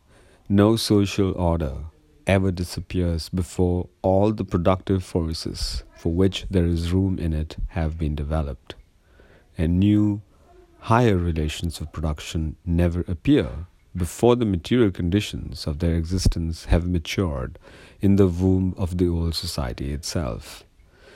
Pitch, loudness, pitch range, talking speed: 90 Hz, -23 LUFS, 80-95 Hz, 130 wpm